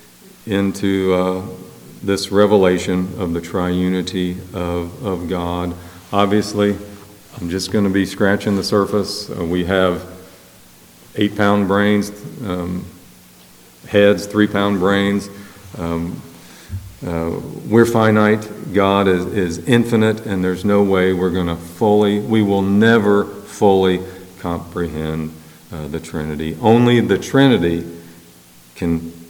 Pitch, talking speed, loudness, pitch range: 95 Hz, 115 wpm, -17 LUFS, 85-100 Hz